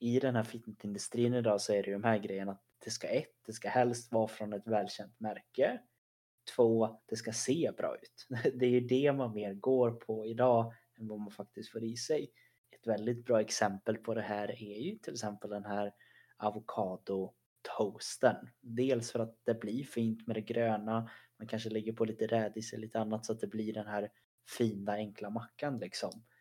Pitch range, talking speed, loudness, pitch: 105-115 Hz, 195 wpm, -35 LUFS, 110 Hz